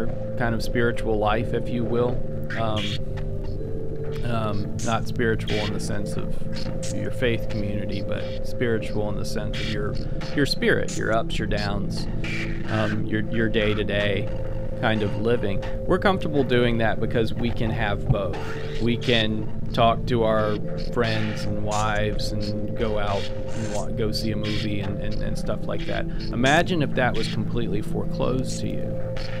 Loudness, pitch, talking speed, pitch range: -25 LUFS, 110 Hz, 160 wpm, 105-115 Hz